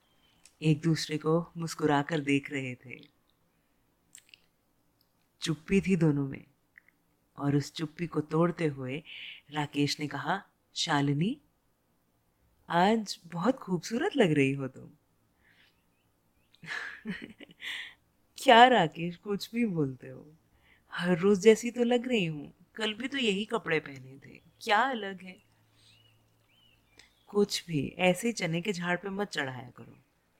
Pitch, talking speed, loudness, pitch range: 165 Hz, 125 wpm, -29 LUFS, 140-205 Hz